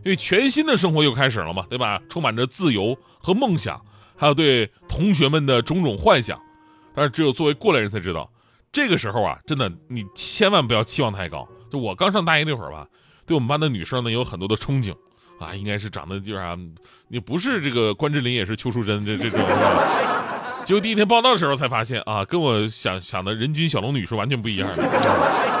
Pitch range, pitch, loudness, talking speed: 105-155 Hz, 125 Hz, -21 LUFS, 335 characters per minute